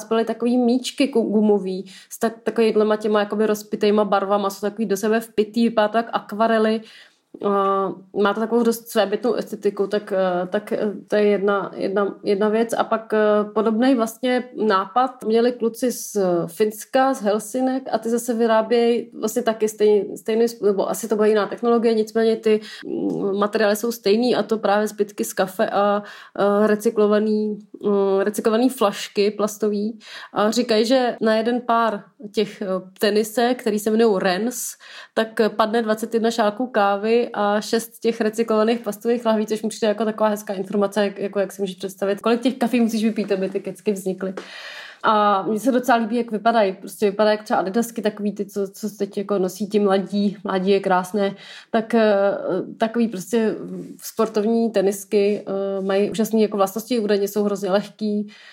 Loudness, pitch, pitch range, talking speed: -21 LUFS, 215 Hz, 205-230 Hz, 160 wpm